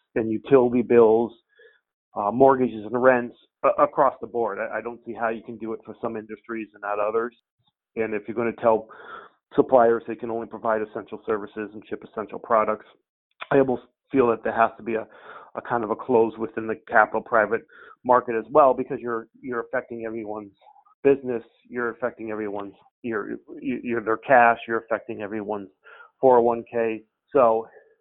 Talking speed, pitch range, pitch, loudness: 175 wpm, 110-120 Hz, 115 Hz, -23 LUFS